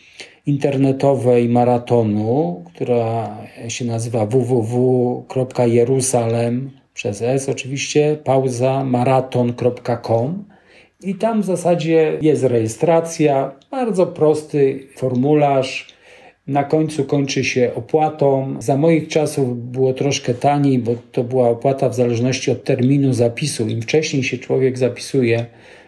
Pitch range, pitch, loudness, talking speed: 125-145 Hz, 130 Hz, -18 LUFS, 105 wpm